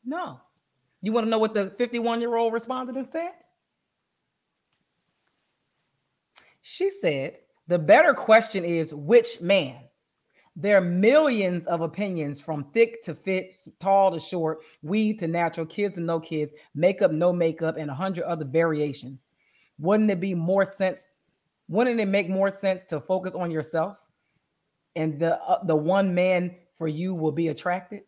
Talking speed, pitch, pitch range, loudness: 150 wpm, 185 Hz, 165-215 Hz, -24 LUFS